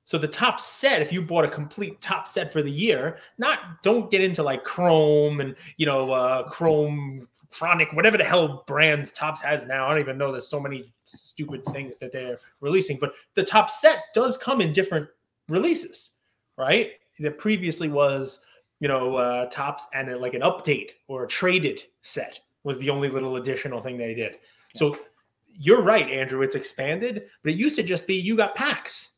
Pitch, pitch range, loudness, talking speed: 150 Hz, 135-195 Hz, -24 LUFS, 195 wpm